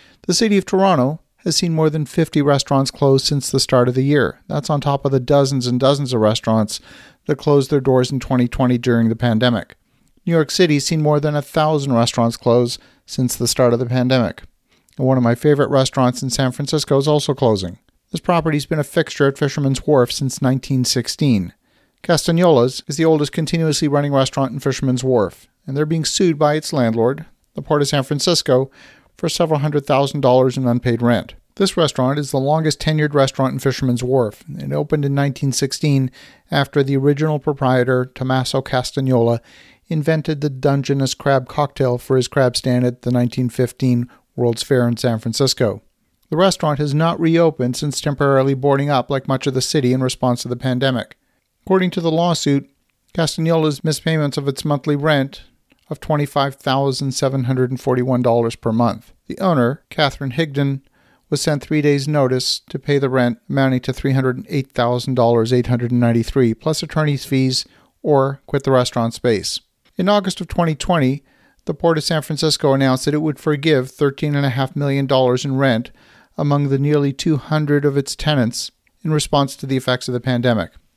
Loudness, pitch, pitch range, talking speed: -18 LUFS, 135 Hz, 125-150 Hz, 190 wpm